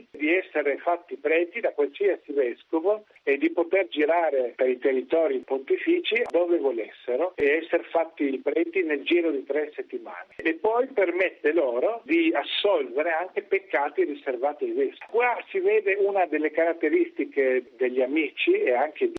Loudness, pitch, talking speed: -25 LUFS, 240 Hz, 150 wpm